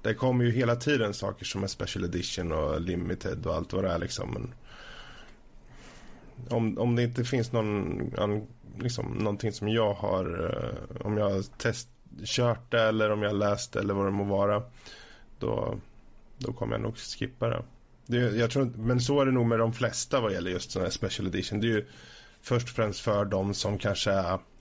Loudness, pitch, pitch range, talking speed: -29 LUFS, 115 Hz, 100-120 Hz, 190 wpm